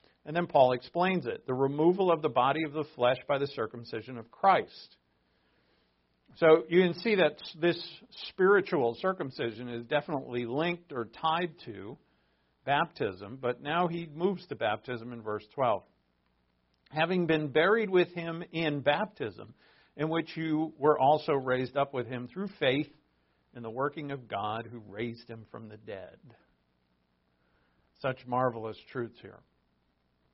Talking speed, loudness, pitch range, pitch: 150 wpm, -30 LUFS, 105-160 Hz, 130 Hz